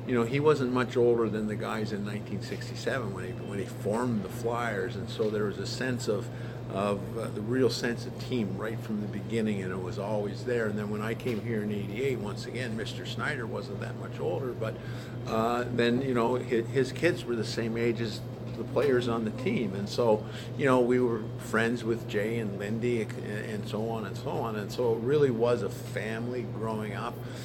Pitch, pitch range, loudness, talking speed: 115 Hz, 110-125 Hz, -31 LUFS, 220 wpm